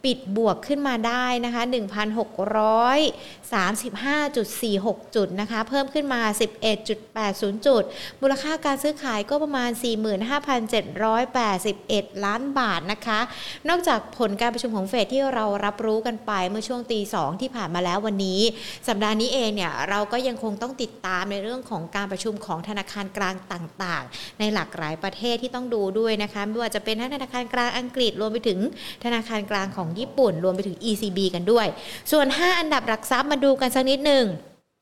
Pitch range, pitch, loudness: 205-250 Hz, 220 Hz, -24 LUFS